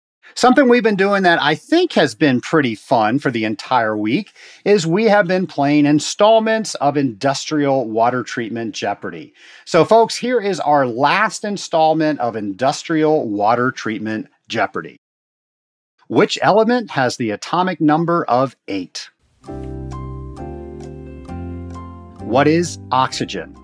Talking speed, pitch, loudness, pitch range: 125 wpm, 145 Hz, -16 LUFS, 110-180 Hz